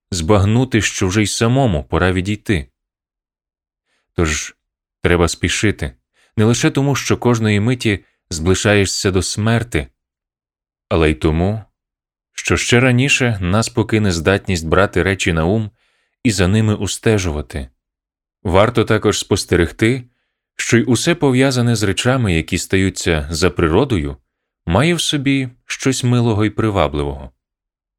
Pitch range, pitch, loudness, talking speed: 85-115 Hz, 100 Hz, -16 LUFS, 120 wpm